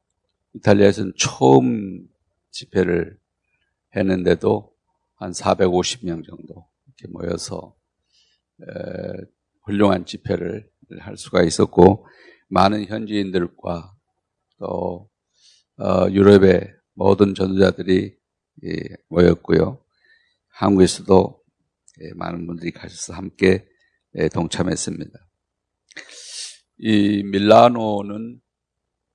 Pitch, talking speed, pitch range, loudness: 95 Hz, 175 characters per minute, 90-100 Hz, -18 LUFS